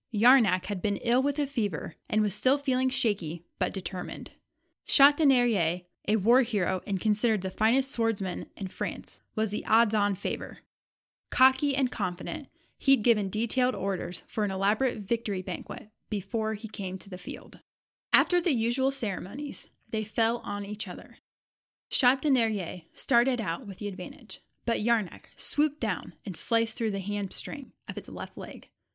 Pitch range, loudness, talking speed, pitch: 195-250 Hz, -28 LUFS, 155 wpm, 220 Hz